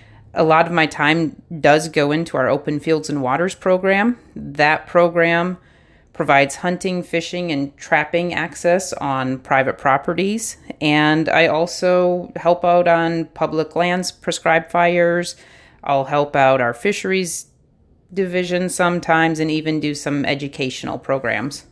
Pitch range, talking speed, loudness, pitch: 145-175 Hz, 135 wpm, -18 LUFS, 165 Hz